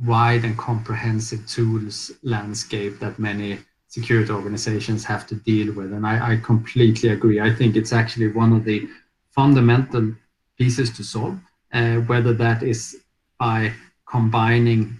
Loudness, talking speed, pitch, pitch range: -21 LUFS, 140 wpm, 115 Hz, 110-120 Hz